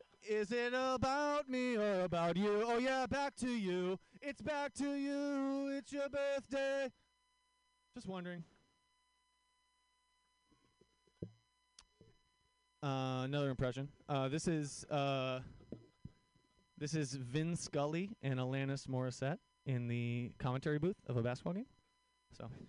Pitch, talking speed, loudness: 210 Hz, 115 wpm, -39 LUFS